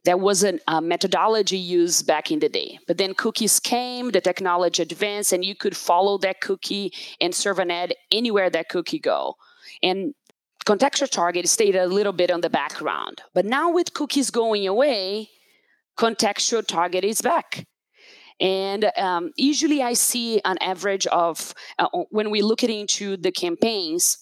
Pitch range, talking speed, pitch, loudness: 180-240 Hz, 165 wpm, 200 Hz, -22 LUFS